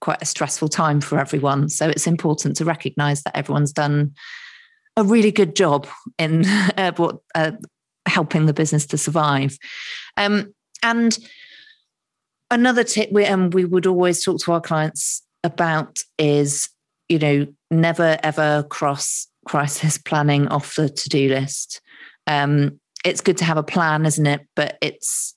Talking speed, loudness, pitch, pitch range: 155 wpm, -19 LUFS, 155 Hz, 145-185 Hz